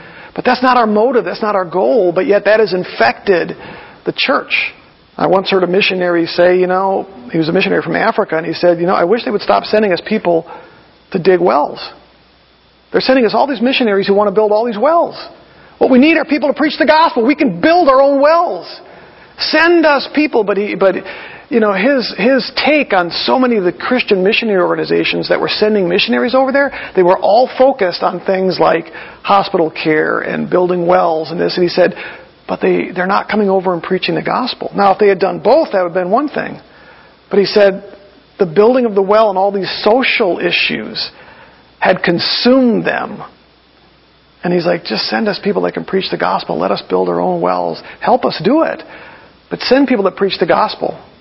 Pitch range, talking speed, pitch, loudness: 180-250 Hz, 215 wpm, 200 Hz, -13 LUFS